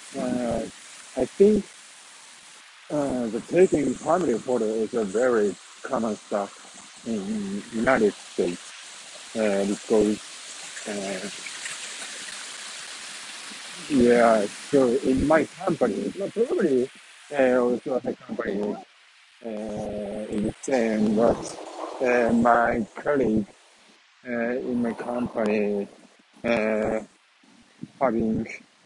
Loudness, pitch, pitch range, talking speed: -25 LUFS, 120 Hz, 110-135 Hz, 85 wpm